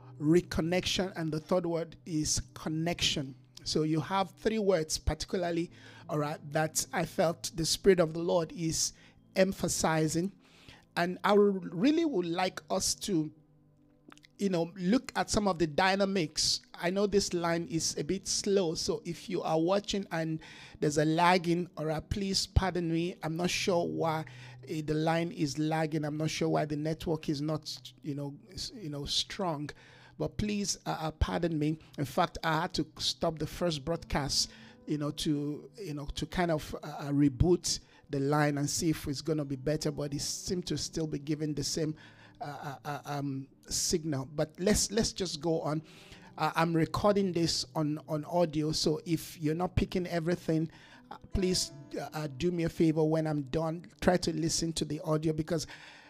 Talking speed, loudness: 180 wpm, -31 LUFS